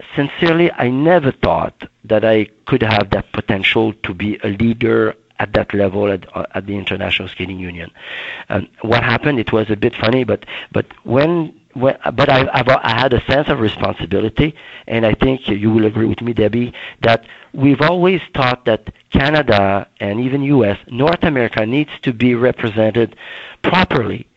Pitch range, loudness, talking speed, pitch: 105-135 Hz, -16 LUFS, 165 wpm, 115 Hz